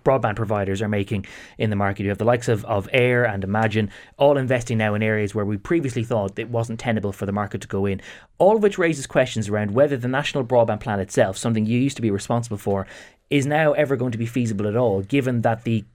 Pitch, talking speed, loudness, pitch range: 115 Hz, 245 wpm, -22 LUFS, 105-130 Hz